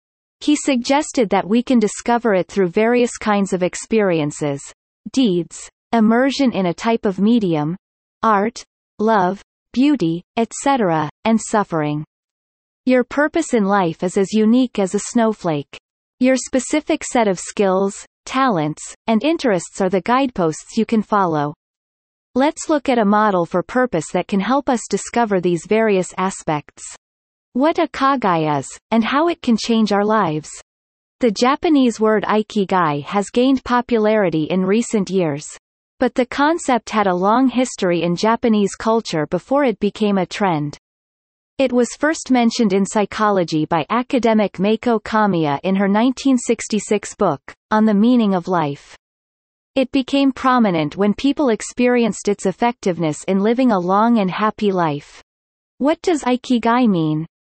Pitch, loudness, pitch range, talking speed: 215 Hz, -18 LUFS, 185-245 Hz, 145 wpm